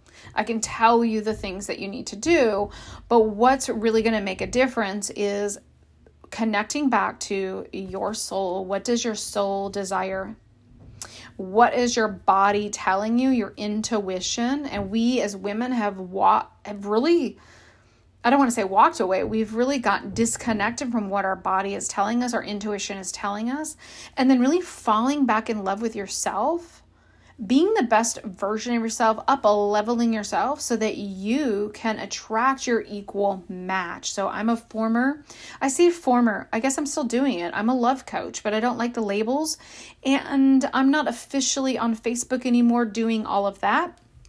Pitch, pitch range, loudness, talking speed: 220 Hz, 200-250 Hz, -23 LUFS, 175 wpm